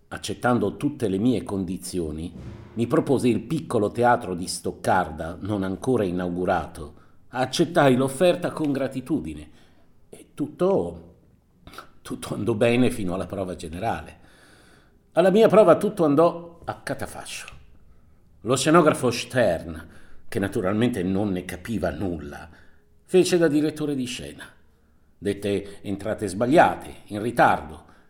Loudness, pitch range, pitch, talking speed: -23 LUFS, 90-130 Hz, 100 Hz, 115 wpm